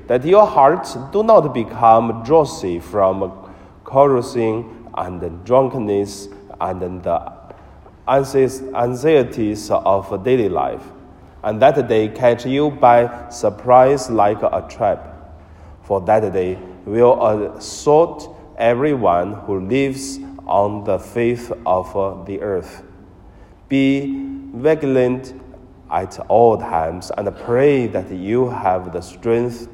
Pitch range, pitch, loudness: 95-130 Hz, 115 Hz, -17 LUFS